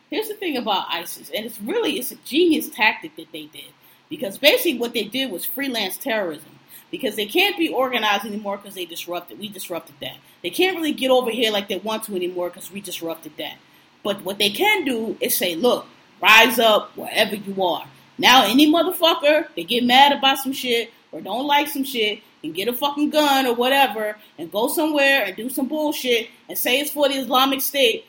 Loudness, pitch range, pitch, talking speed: -19 LUFS, 210-295 Hz, 250 Hz, 210 wpm